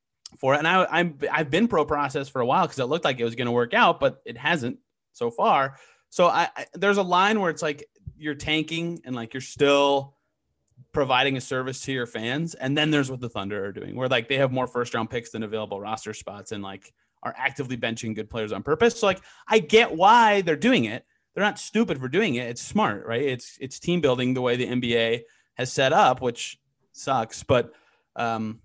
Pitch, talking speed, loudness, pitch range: 130 Hz, 230 wpm, -24 LUFS, 120-155 Hz